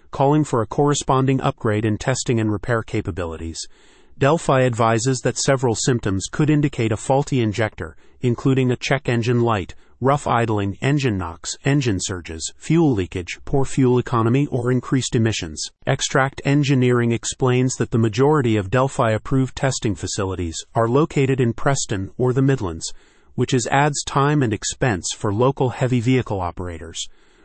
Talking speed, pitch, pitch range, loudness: 150 wpm, 125 Hz, 105-135 Hz, -20 LUFS